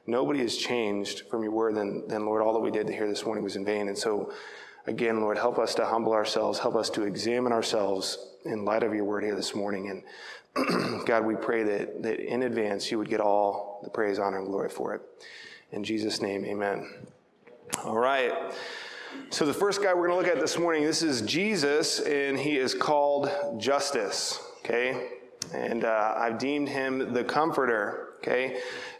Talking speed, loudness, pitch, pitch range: 195 wpm, -28 LUFS, 115 Hz, 105-160 Hz